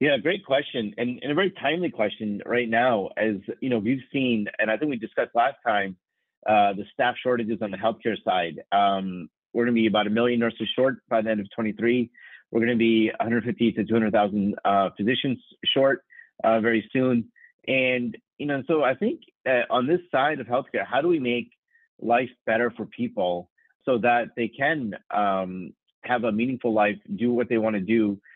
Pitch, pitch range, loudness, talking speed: 115 Hz, 105-125 Hz, -25 LUFS, 195 wpm